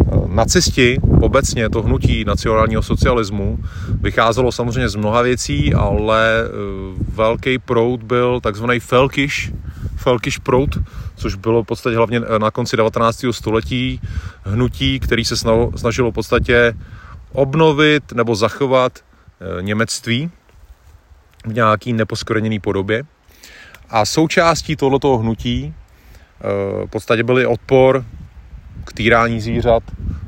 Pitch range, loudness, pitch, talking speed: 100-125 Hz, -16 LUFS, 115 Hz, 105 wpm